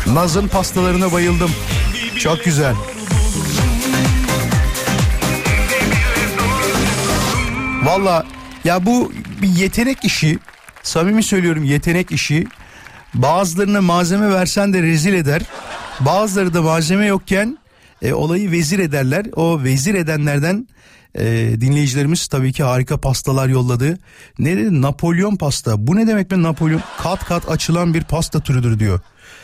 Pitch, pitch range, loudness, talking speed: 165 Hz, 140-190 Hz, -16 LUFS, 110 wpm